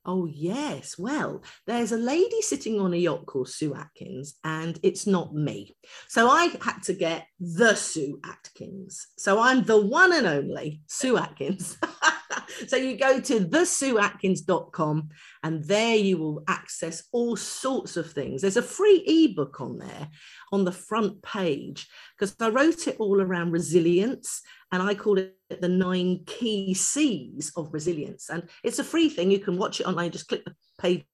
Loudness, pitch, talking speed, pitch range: -25 LUFS, 190 Hz, 170 wpm, 170-235 Hz